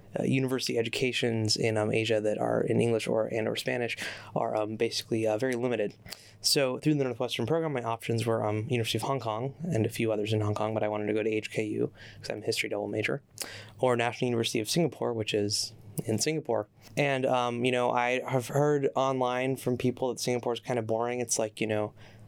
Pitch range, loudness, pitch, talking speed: 110-125 Hz, -29 LUFS, 120 Hz, 220 wpm